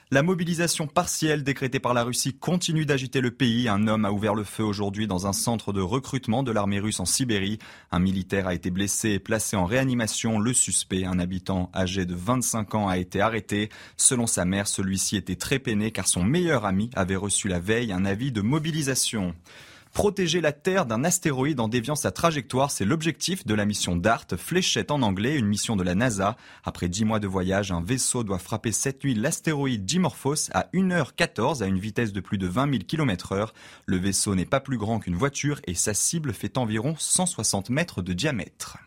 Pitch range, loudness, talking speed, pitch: 100-135 Hz, -25 LUFS, 205 wpm, 110 Hz